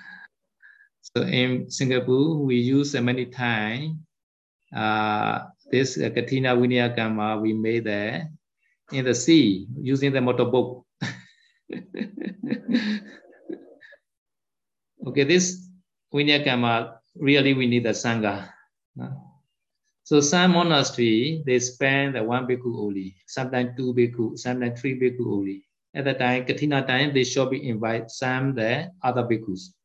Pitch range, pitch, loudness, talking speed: 115-145 Hz, 125 Hz, -23 LUFS, 120 wpm